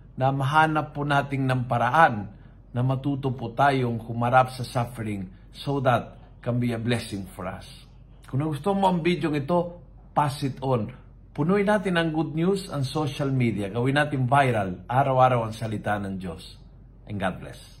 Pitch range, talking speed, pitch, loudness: 115-145 Hz, 165 wpm, 130 Hz, -25 LUFS